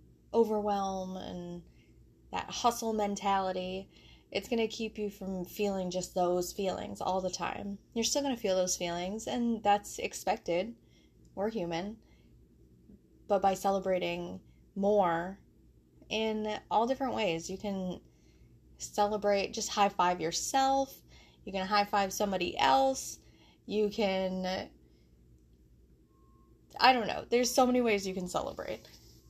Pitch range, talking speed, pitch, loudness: 175-210 Hz, 130 wpm, 195 Hz, -32 LUFS